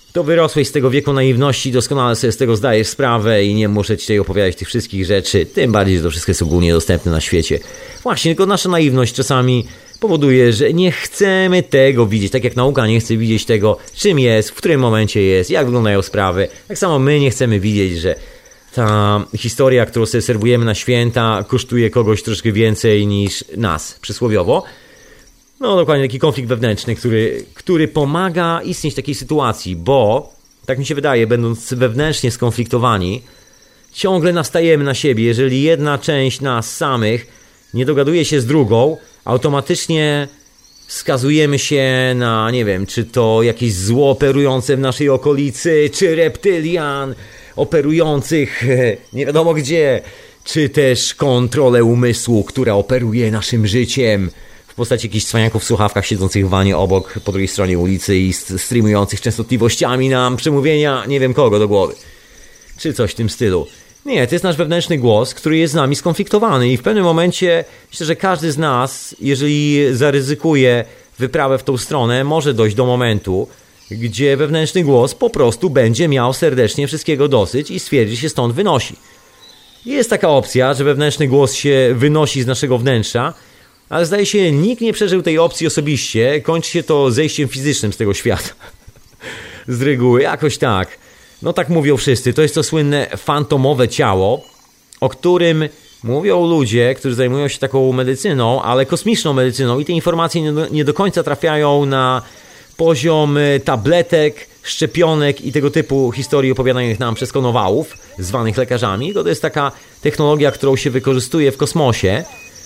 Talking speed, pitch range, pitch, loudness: 160 wpm, 115-150 Hz, 130 Hz, -15 LUFS